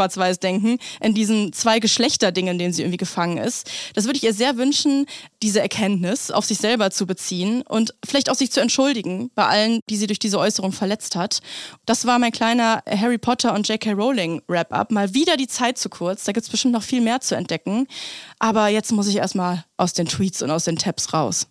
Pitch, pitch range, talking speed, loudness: 215 Hz, 190-240 Hz, 210 wpm, -20 LUFS